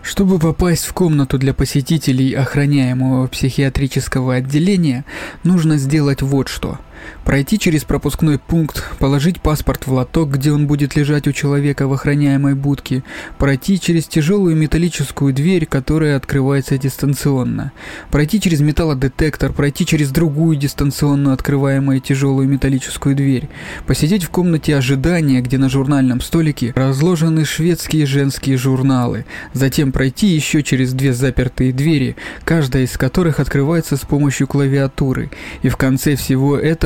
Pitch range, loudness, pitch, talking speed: 135-155 Hz, -16 LUFS, 140 Hz, 130 wpm